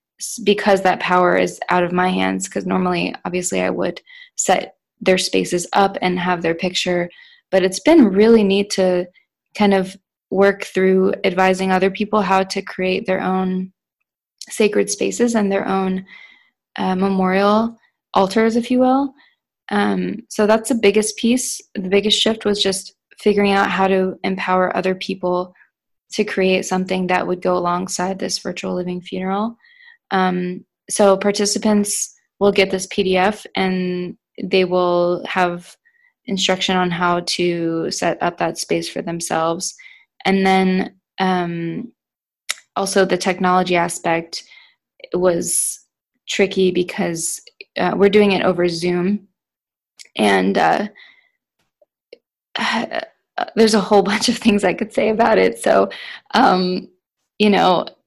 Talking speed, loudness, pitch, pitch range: 140 wpm, -18 LUFS, 190 Hz, 180-210 Hz